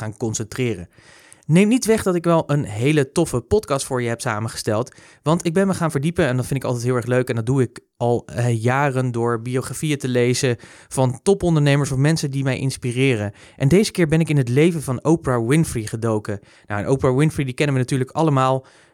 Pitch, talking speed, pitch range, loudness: 130 Hz, 220 wpm, 120-150 Hz, -20 LUFS